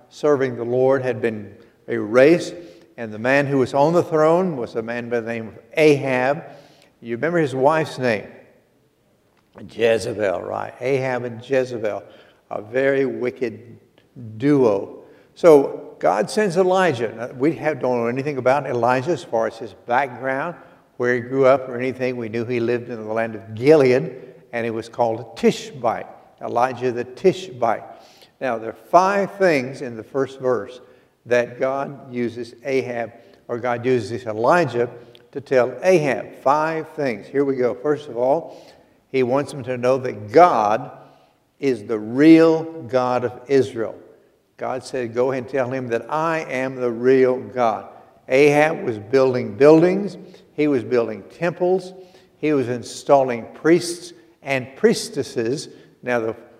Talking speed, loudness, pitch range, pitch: 155 wpm, -20 LUFS, 120-150 Hz, 130 Hz